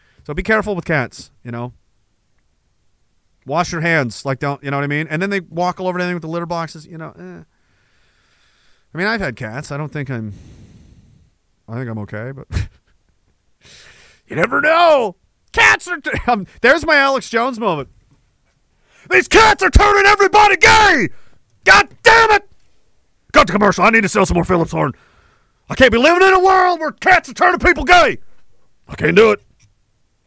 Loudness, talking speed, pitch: -13 LUFS, 185 wpm, 175 Hz